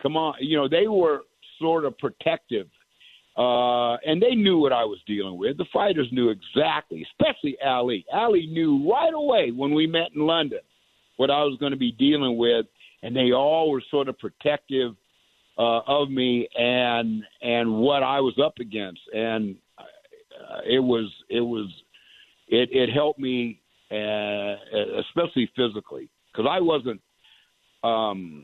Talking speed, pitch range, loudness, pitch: 160 wpm, 115-160 Hz, -24 LUFS, 130 Hz